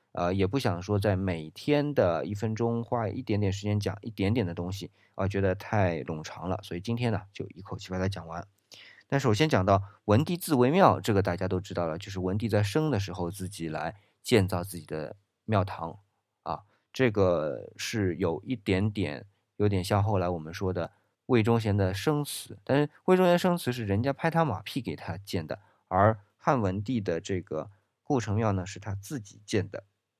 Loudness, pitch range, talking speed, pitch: -29 LUFS, 95-115 Hz, 280 characters per minute, 100 Hz